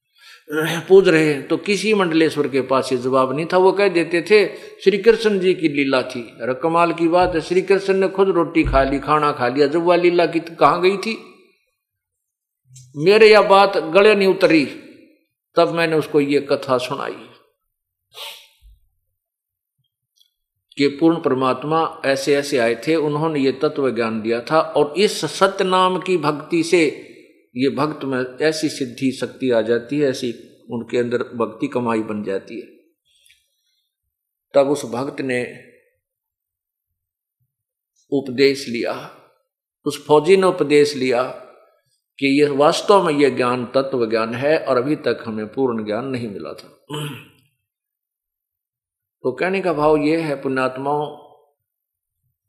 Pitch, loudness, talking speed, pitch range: 145 Hz, -18 LUFS, 145 wpm, 125-180 Hz